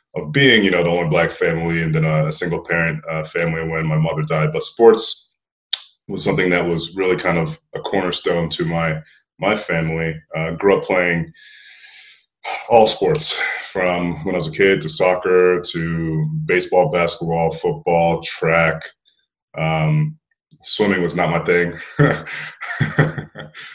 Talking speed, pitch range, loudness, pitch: 150 wpm, 80-85 Hz, -18 LUFS, 85 Hz